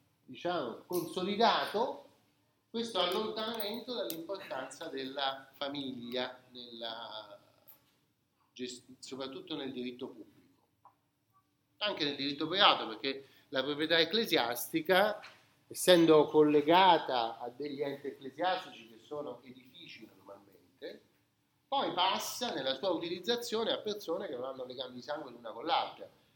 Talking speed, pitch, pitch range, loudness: 105 wpm, 145 Hz, 130-180 Hz, -33 LUFS